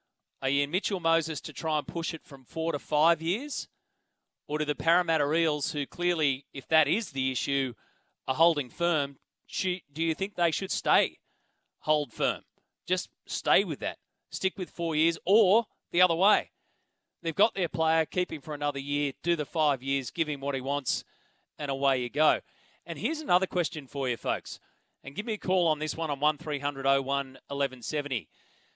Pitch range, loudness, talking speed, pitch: 140-175 Hz, -29 LUFS, 190 wpm, 155 Hz